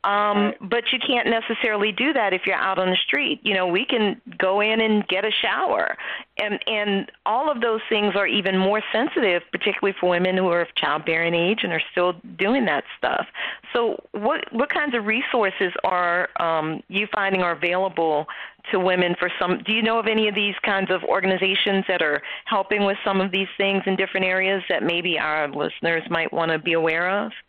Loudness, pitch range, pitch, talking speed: -22 LUFS, 180-215 Hz, 195 Hz, 205 wpm